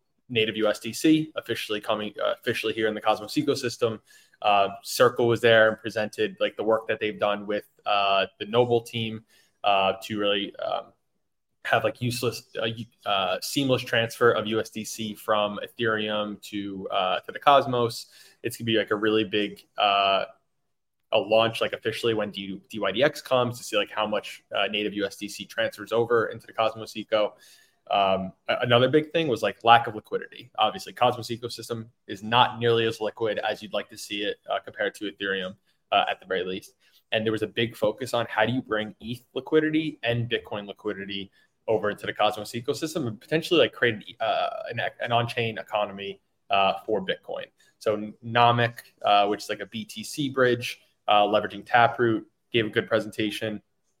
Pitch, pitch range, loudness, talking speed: 110 Hz, 105-120 Hz, -26 LUFS, 180 wpm